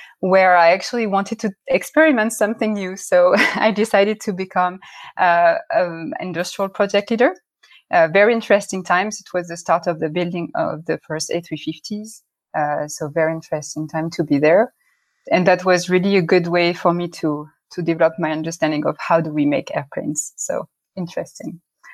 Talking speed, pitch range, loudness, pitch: 170 wpm, 165-210 Hz, -19 LUFS, 180 Hz